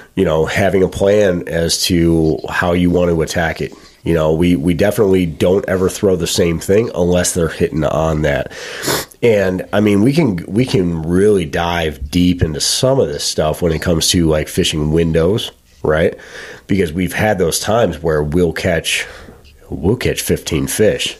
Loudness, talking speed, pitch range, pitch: -15 LUFS, 180 wpm, 80-90 Hz, 85 Hz